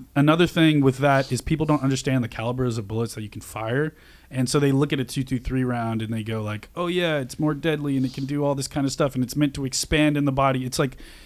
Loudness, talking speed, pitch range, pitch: -23 LUFS, 275 wpm, 125-150 Hz, 135 Hz